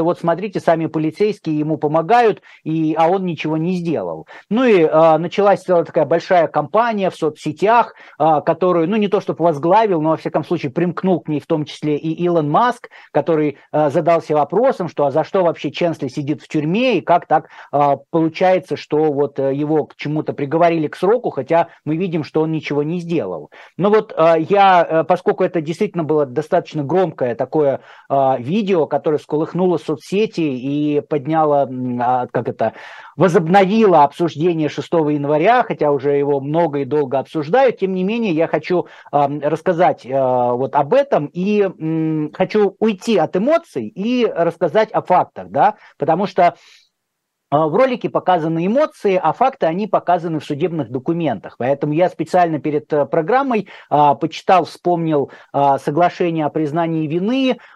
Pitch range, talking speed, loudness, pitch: 150-185 Hz, 155 wpm, -17 LUFS, 165 Hz